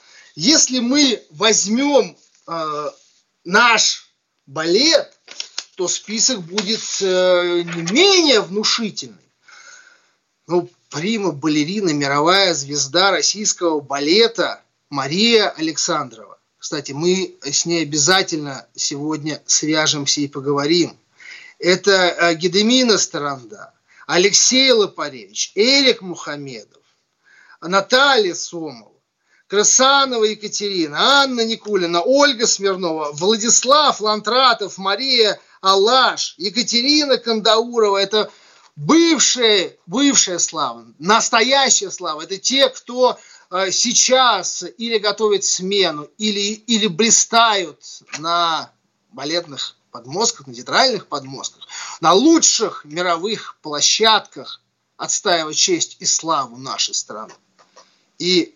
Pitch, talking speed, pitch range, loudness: 200 Hz, 85 wpm, 170-235 Hz, -16 LUFS